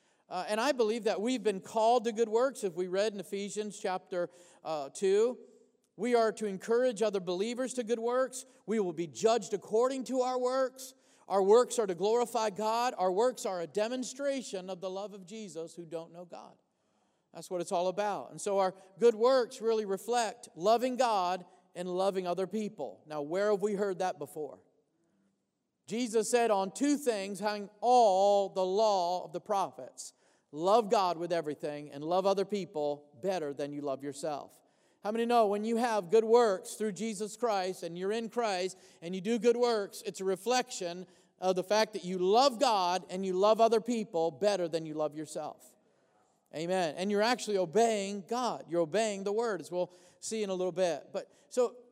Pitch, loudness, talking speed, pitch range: 205 Hz, -31 LUFS, 190 wpm, 180-230 Hz